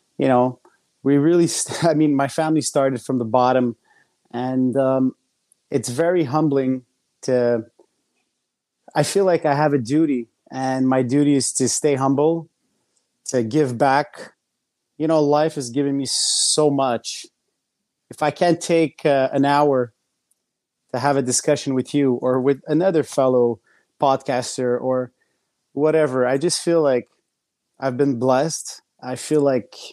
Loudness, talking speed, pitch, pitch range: -20 LUFS, 150 wpm, 135 Hz, 130-150 Hz